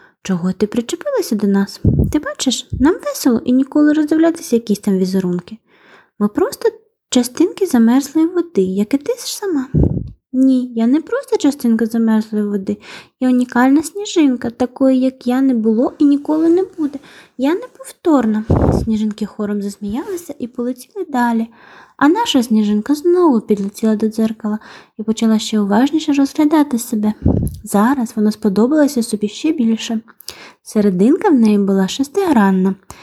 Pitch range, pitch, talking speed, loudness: 215-300 Hz, 250 Hz, 140 wpm, -16 LUFS